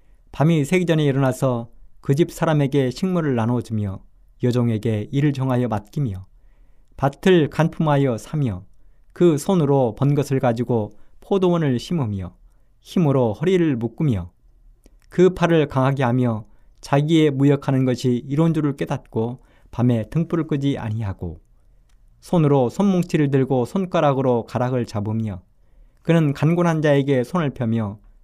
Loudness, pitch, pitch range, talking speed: -20 LUFS, 135 Hz, 115-155 Hz, 290 characters per minute